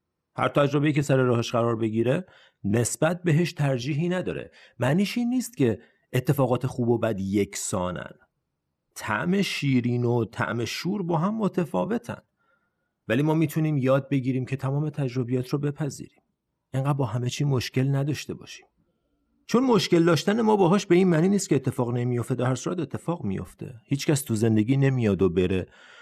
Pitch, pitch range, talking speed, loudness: 135 Hz, 120-165 Hz, 160 wpm, -25 LUFS